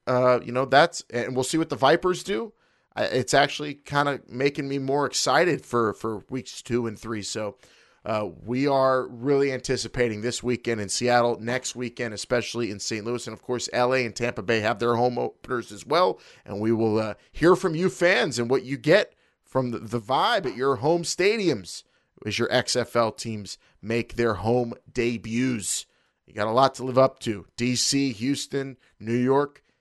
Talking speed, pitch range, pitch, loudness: 190 wpm, 115-135 Hz, 125 Hz, -25 LUFS